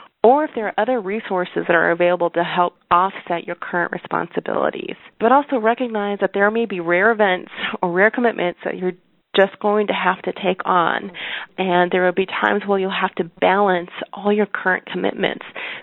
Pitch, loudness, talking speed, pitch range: 190 Hz, -19 LUFS, 190 wpm, 180-215 Hz